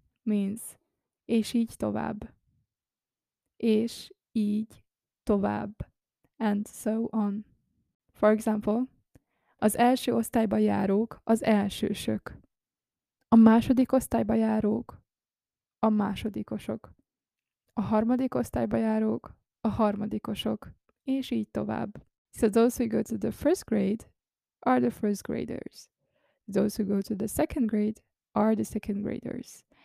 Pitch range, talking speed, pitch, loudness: 210-235 Hz, 115 wpm, 220 Hz, -28 LUFS